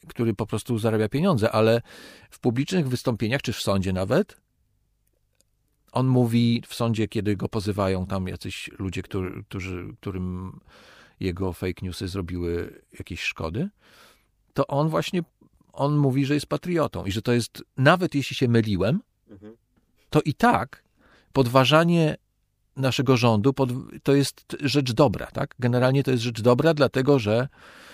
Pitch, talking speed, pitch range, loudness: 120 Hz, 140 wpm, 105-140 Hz, -24 LUFS